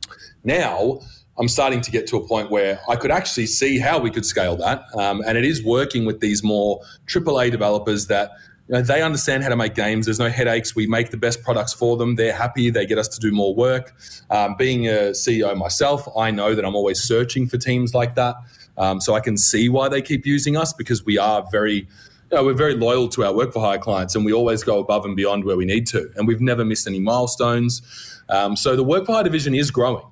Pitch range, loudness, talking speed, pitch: 105-125 Hz, -20 LUFS, 245 wpm, 115 Hz